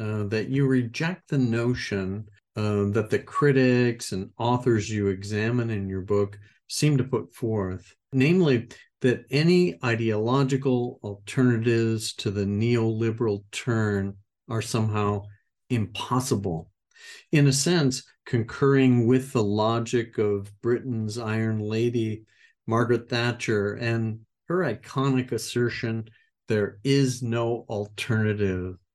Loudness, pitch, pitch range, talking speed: -25 LUFS, 115 Hz, 105-125 Hz, 110 wpm